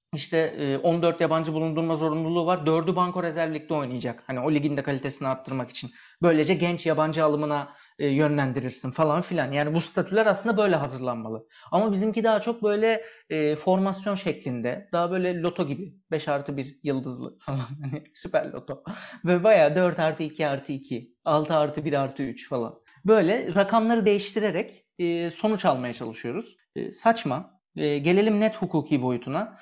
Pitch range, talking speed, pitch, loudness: 140-185 Hz, 145 wpm, 160 Hz, -25 LUFS